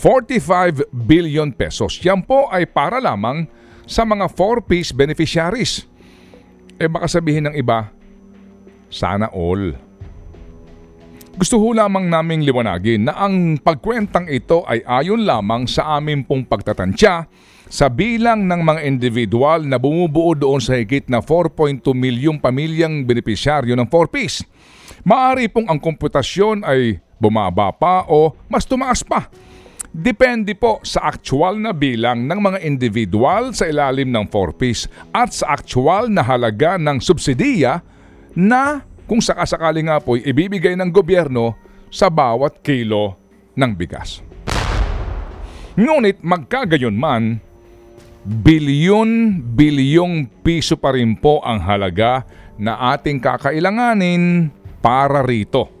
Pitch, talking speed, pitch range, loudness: 145 Hz, 120 wpm, 115-180 Hz, -16 LUFS